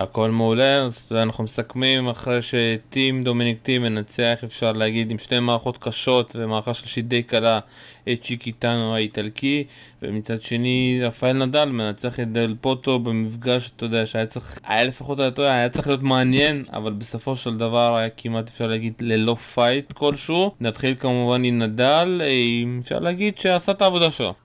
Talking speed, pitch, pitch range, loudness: 165 wpm, 120 Hz, 115-130 Hz, -21 LUFS